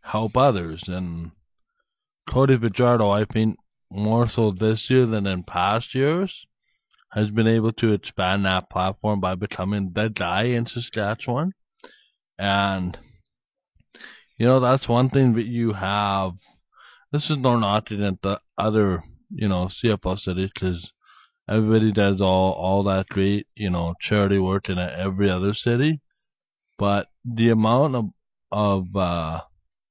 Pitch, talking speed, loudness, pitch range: 105 Hz, 140 wpm, -22 LUFS, 95-120 Hz